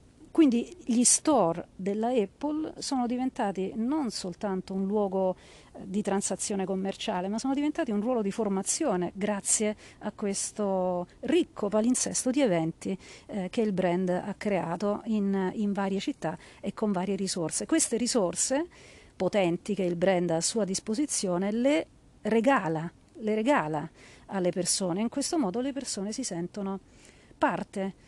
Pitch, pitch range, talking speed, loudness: 205 Hz, 185-240 Hz, 145 wpm, -29 LUFS